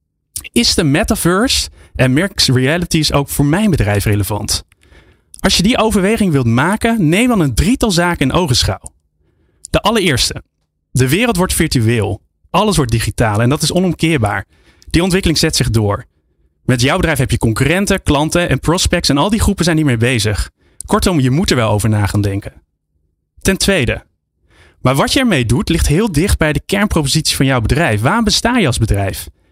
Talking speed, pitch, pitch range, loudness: 180 wpm, 130 Hz, 100-170 Hz, -14 LUFS